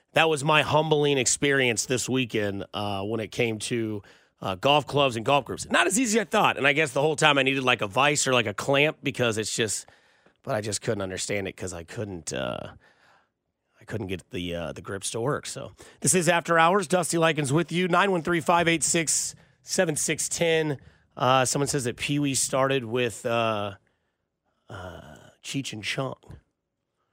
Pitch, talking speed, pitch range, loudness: 135 Hz, 190 wpm, 115-160 Hz, -24 LUFS